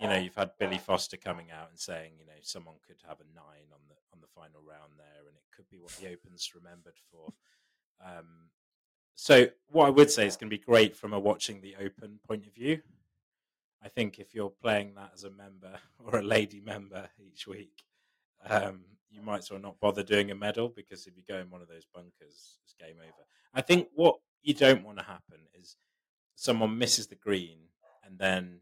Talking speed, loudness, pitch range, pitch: 220 wpm, -28 LUFS, 85-105 Hz, 100 Hz